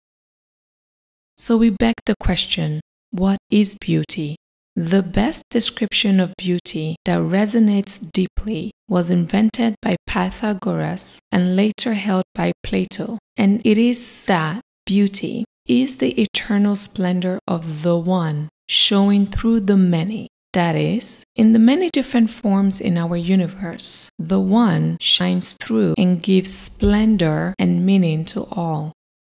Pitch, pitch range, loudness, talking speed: 195 Hz, 180-220 Hz, -18 LUFS, 125 wpm